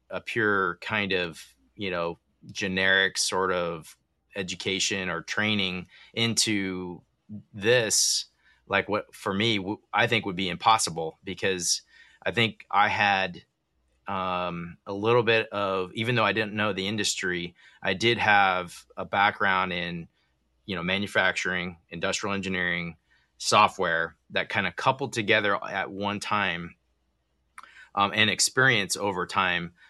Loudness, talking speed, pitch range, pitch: -25 LUFS, 130 wpm, 90-105 Hz, 95 Hz